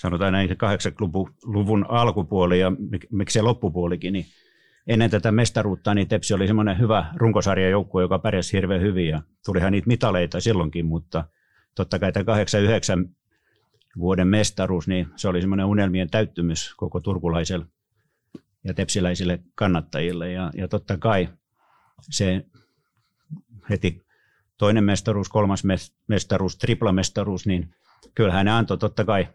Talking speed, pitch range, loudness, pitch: 125 wpm, 90-105 Hz, -23 LUFS, 95 Hz